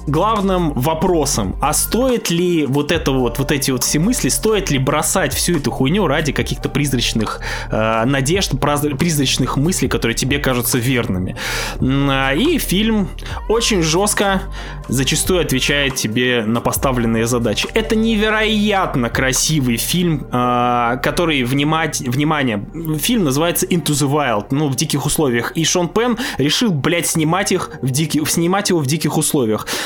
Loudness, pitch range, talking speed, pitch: -16 LUFS, 130-175 Hz, 145 wpm, 150 Hz